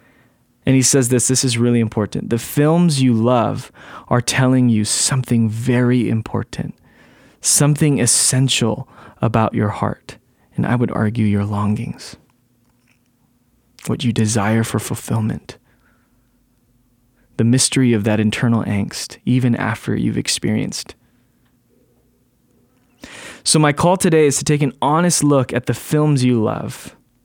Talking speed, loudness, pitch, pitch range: 130 wpm, -17 LUFS, 125 Hz, 115-130 Hz